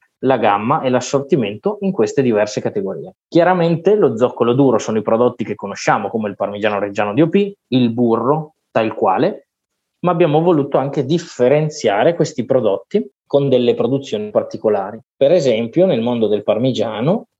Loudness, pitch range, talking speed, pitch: -16 LUFS, 120-165 Hz, 150 wpm, 135 Hz